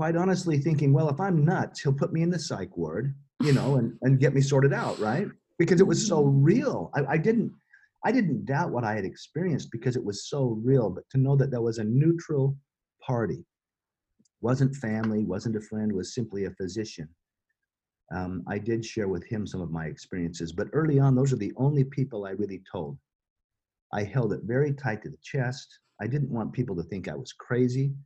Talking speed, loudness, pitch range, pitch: 210 wpm, -27 LUFS, 105-145 Hz, 130 Hz